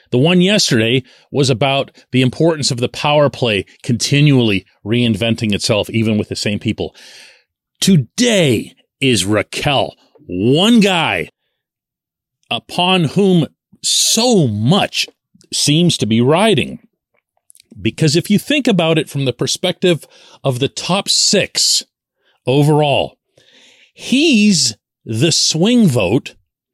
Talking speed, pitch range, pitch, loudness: 110 wpm, 120-180 Hz, 140 Hz, -14 LUFS